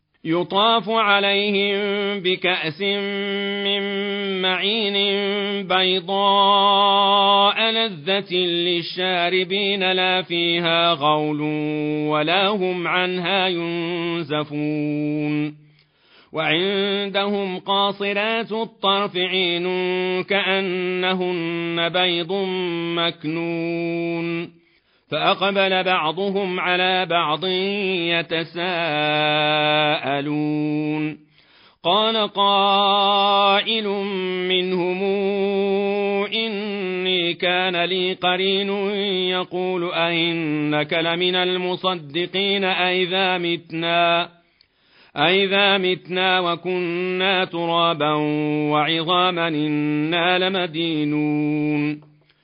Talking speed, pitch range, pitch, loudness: 55 wpm, 170-200 Hz, 180 Hz, -20 LUFS